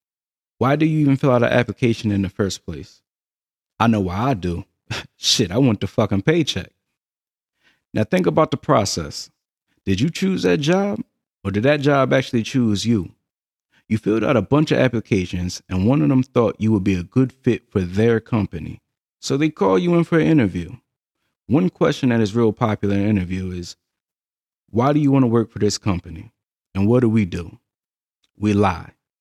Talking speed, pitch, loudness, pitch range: 195 wpm, 115 Hz, -19 LUFS, 100-135 Hz